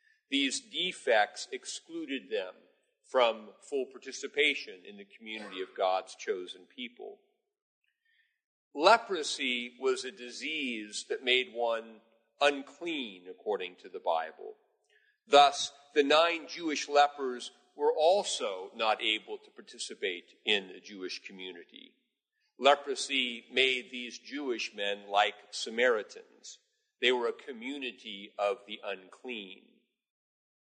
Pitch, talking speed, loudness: 225 Hz, 110 wpm, -31 LUFS